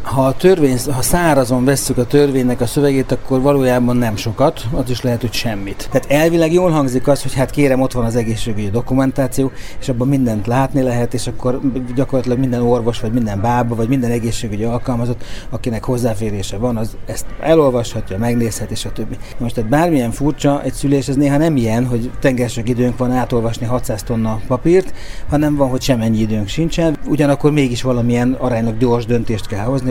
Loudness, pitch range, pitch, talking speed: -16 LUFS, 115-135 Hz, 125 Hz, 185 wpm